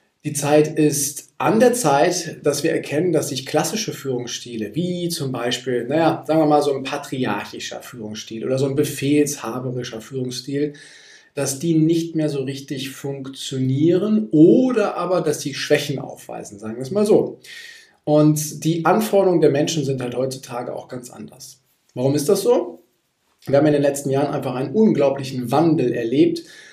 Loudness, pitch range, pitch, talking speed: -20 LUFS, 130-160 Hz, 145 Hz, 165 wpm